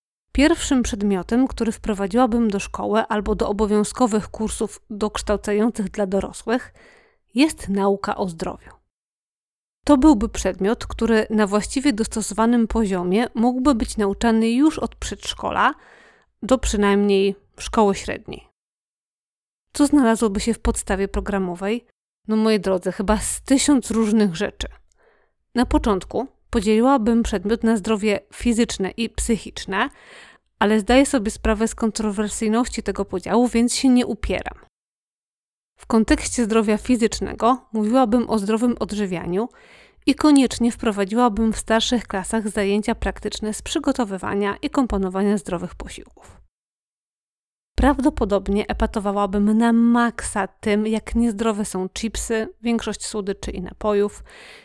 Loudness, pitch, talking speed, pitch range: -21 LUFS, 225 Hz, 115 wpm, 205-240 Hz